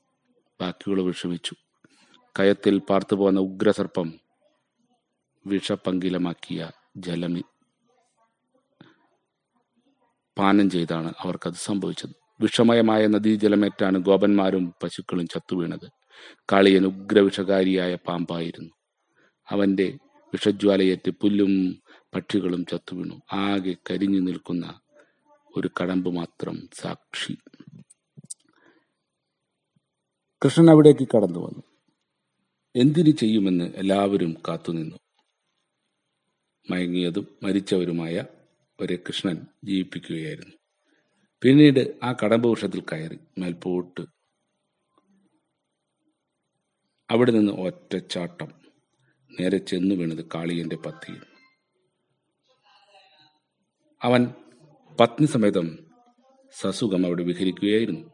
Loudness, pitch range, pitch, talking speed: -23 LUFS, 90-140 Hz, 100 Hz, 65 wpm